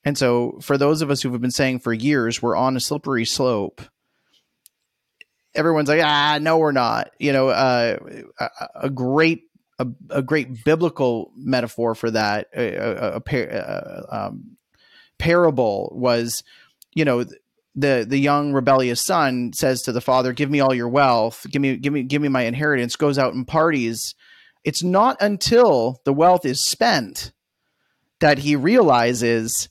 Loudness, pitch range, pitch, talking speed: -20 LUFS, 120-150 Hz, 135 Hz, 165 wpm